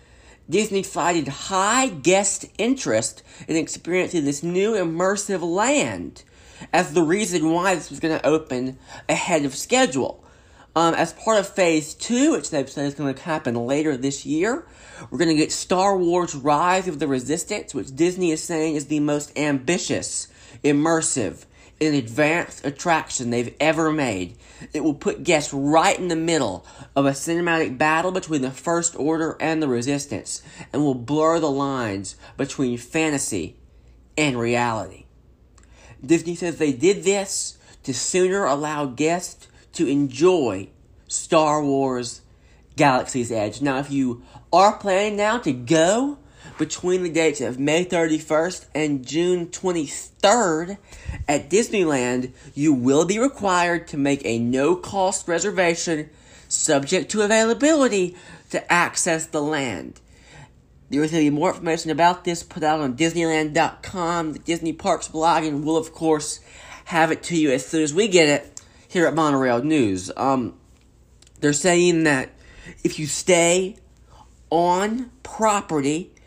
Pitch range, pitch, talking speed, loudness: 140-175 Hz, 160 Hz, 145 wpm, -21 LUFS